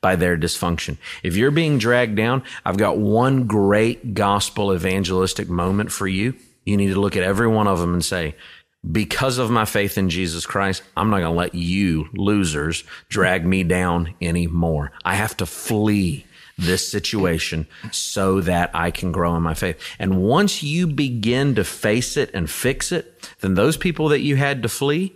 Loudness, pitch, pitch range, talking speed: -20 LUFS, 100 Hz, 90-115 Hz, 185 wpm